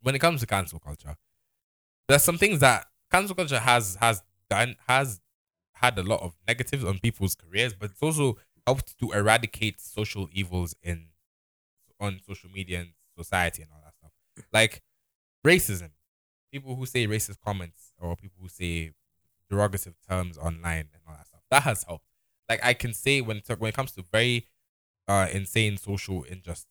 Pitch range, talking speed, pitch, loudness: 85-115 Hz, 175 wpm, 100 Hz, -26 LUFS